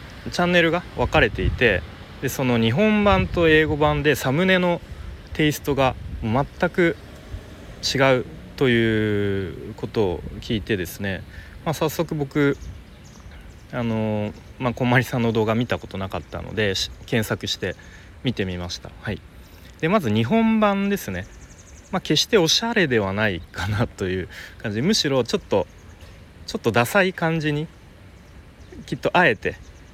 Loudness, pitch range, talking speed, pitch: -22 LUFS, 95-150 Hz, 285 characters per minute, 110 Hz